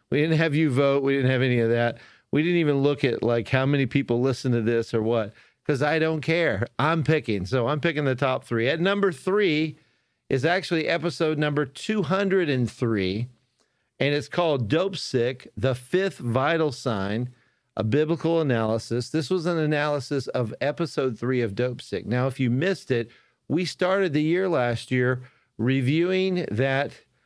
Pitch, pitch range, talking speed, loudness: 140 Hz, 120-160 Hz, 175 wpm, -24 LUFS